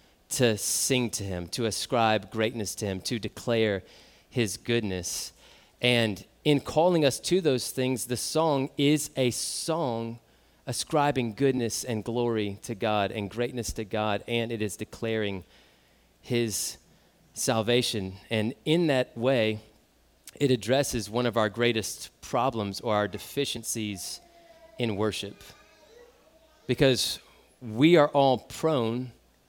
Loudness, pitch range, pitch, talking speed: -27 LUFS, 105-130 Hz, 115 Hz, 125 wpm